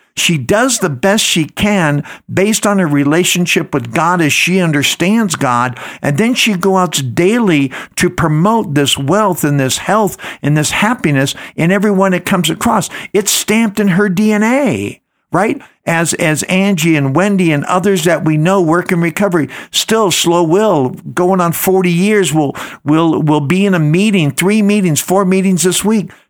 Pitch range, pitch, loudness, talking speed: 155-200 Hz, 180 Hz, -12 LUFS, 175 wpm